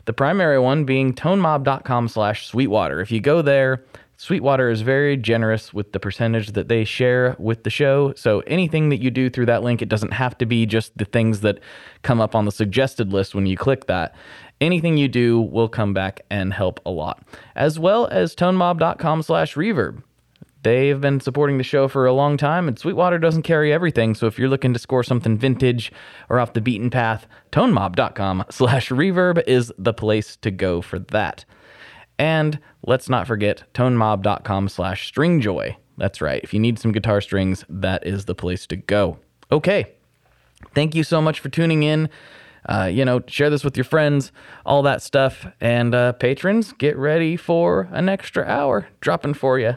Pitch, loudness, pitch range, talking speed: 125 Hz, -20 LUFS, 110-145 Hz, 190 wpm